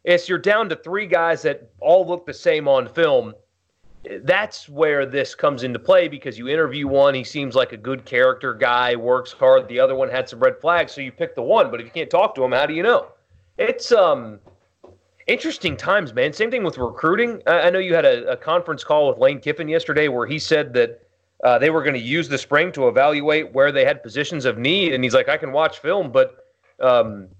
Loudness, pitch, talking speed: -19 LUFS, 175 Hz, 230 wpm